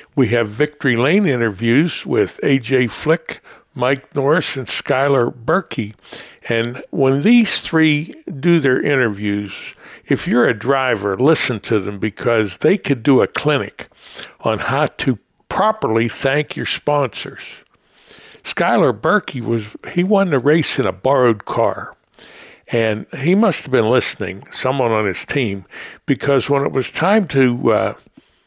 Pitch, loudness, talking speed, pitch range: 135 Hz, -17 LUFS, 140 wpm, 115-155 Hz